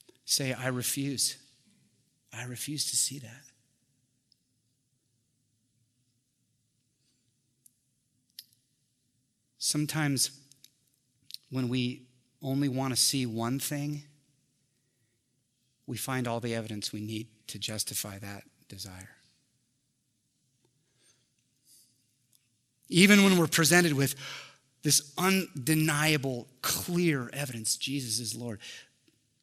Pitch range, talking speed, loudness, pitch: 120-140 Hz, 80 wpm, -28 LUFS, 130 Hz